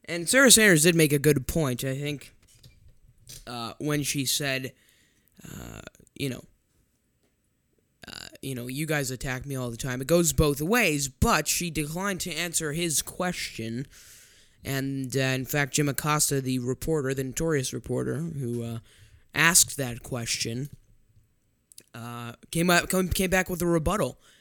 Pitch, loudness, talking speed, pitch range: 135 Hz, -25 LUFS, 150 wpm, 125-160 Hz